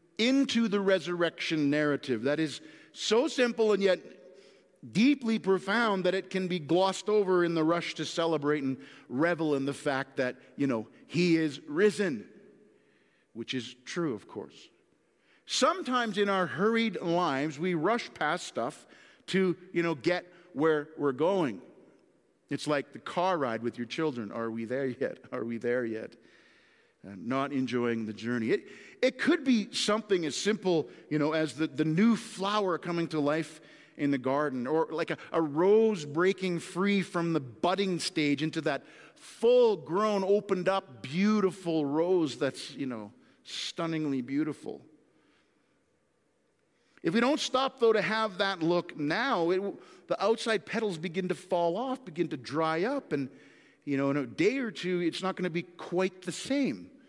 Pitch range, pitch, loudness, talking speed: 150-200 Hz, 175 Hz, -30 LUFS, 165 wpm